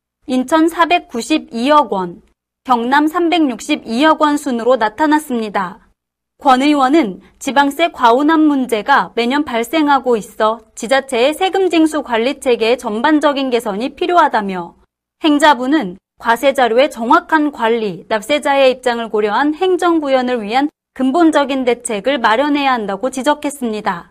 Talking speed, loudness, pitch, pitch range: 285 characters per minute, -14 LUFS, 265 Hz, 230-300 Hz